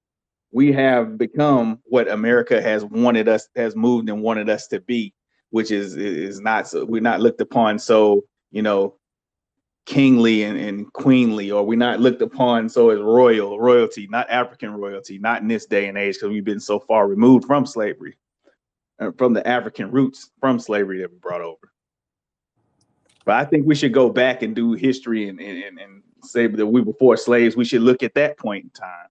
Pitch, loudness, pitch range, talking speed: 120 Hz, -18 LUFS, 105-130 Hz, 195 wpm